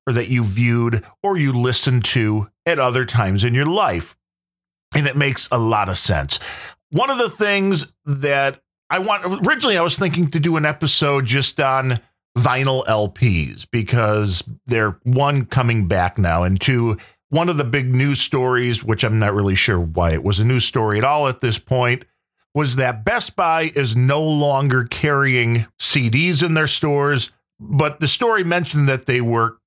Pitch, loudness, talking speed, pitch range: 125 Hz, -18 LUFS, 180 wpm, 110-145 Hz